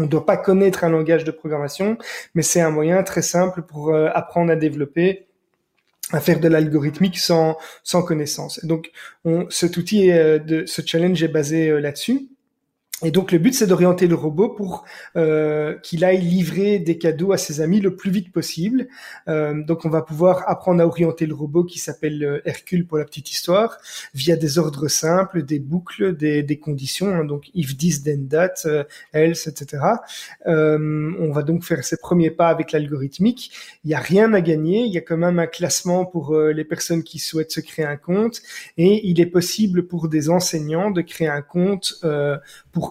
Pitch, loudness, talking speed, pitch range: 165 Hz, -20 LUFS, 195 wpm, 155-180 Hz